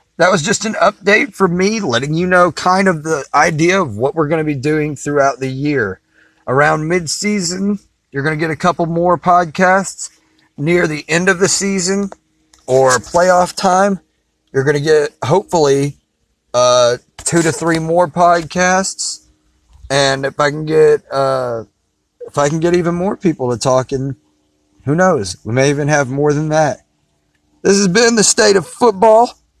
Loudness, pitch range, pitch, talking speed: -14 LUFS, 135-185 Hz, 155 Hz, 175 wpm